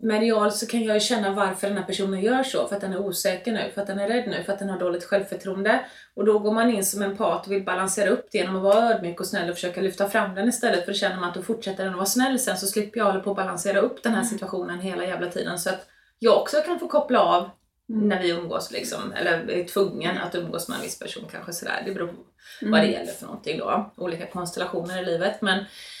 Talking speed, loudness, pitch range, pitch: 275 wpm, -25 LUFS, 185-215 Hz, 200 Hz